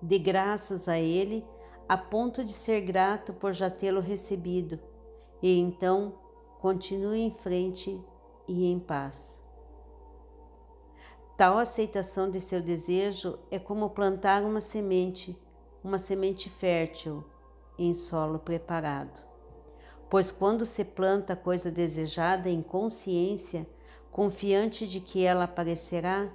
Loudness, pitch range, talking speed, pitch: -30 LUFS, 180-200 Hz, 115 wpm, 190 Hz